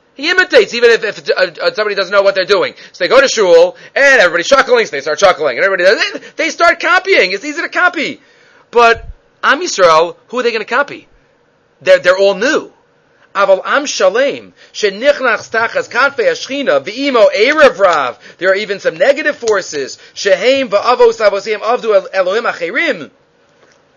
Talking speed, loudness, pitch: 140 wpm, -11 LUFS, 290 Hz